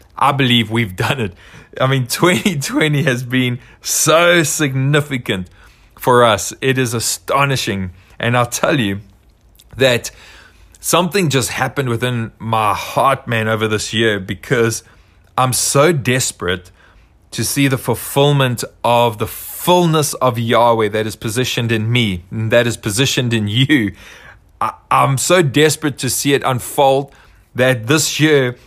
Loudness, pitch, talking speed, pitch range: -15 LUFS, 120 Hz, 140 wpm, 110-135 Hz